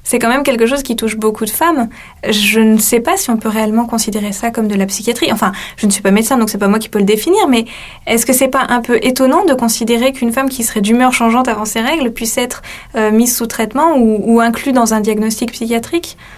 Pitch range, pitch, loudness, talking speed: 220-255 Hz, 230 Hz, -13 LUFS, 255 wpm